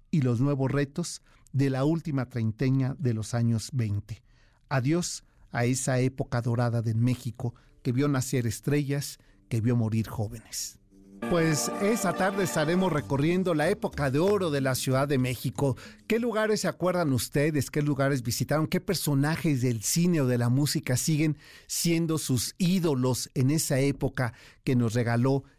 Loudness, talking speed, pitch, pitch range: -27 LUFS, 155 wpm, 135 Hz, 120-155 Hz